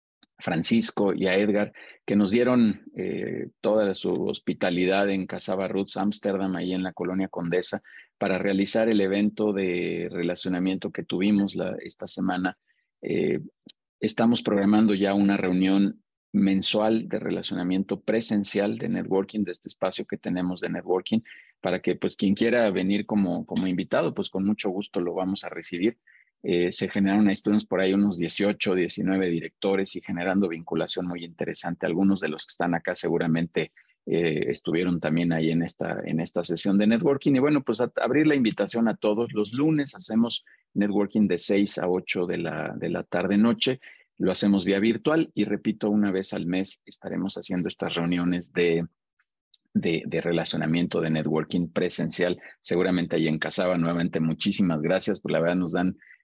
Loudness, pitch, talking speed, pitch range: -26 LUFS, 95 Hz, 160 wpm, 90-105 Hz